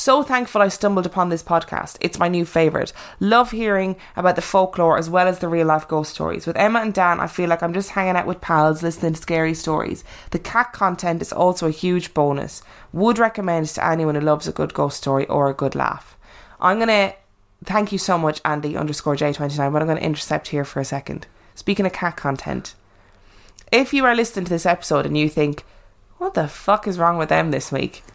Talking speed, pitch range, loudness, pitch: 220 wpm, 150-190 Hz, -20 LUFS, 170 Hz